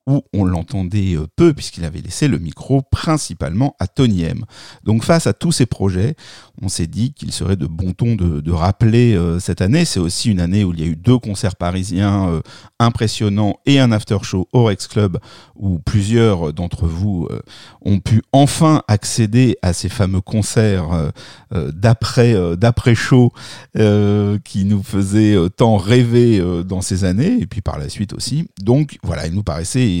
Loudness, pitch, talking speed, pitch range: -16 LUFS, 105 Hz, 185 wpm, 90-120 Hz